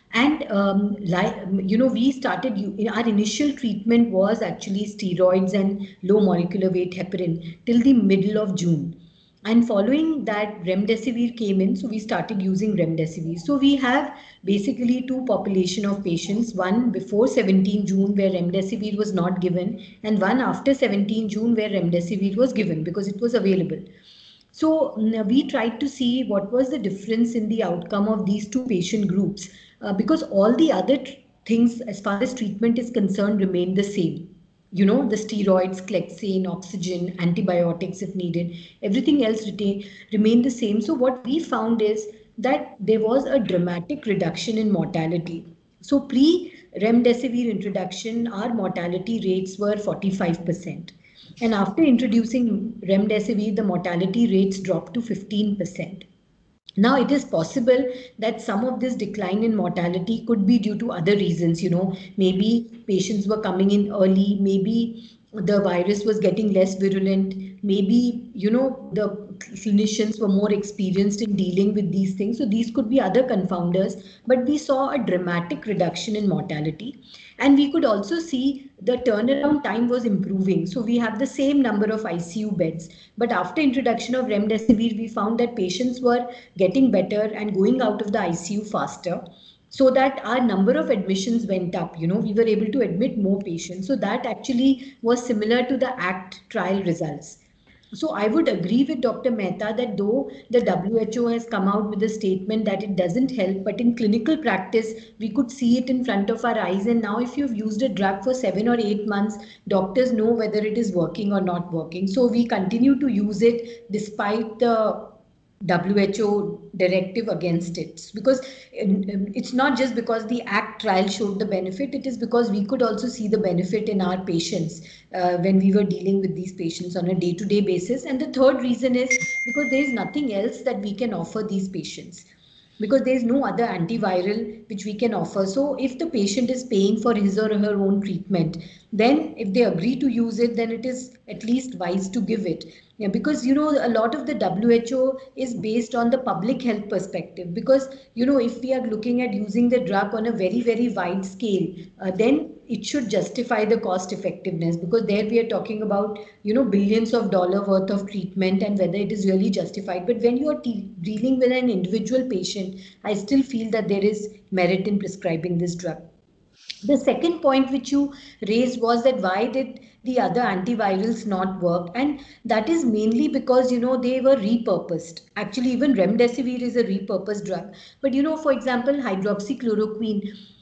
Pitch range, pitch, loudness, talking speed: 190-240 Hz, 215 Hz, -22 LUFS, 180 wpm